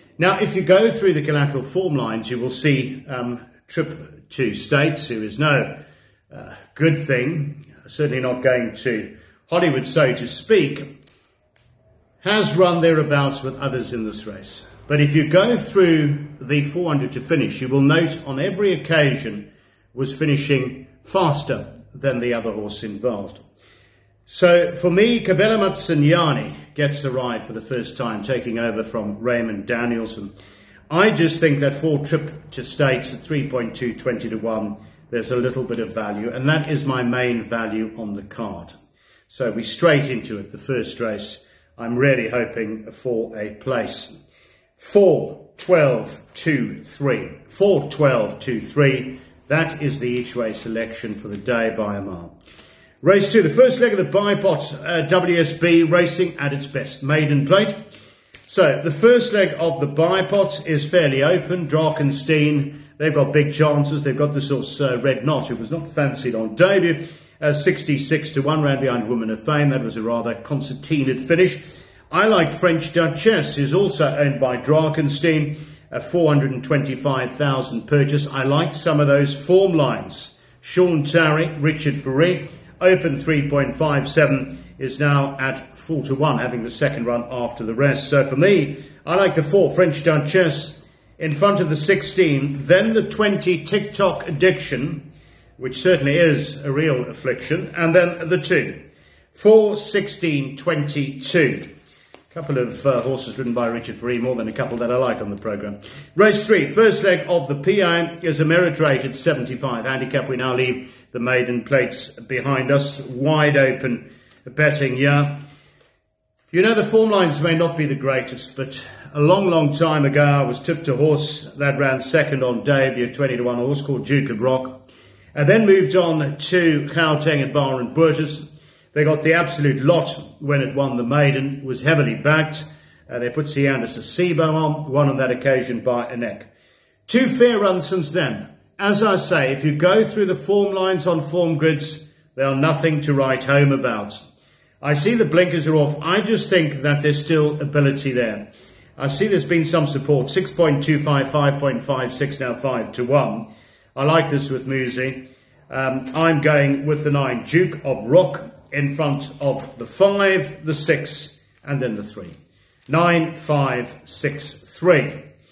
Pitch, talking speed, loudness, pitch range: 145 Hz, 170 wpm, -19 LUFS, 130-165 Hz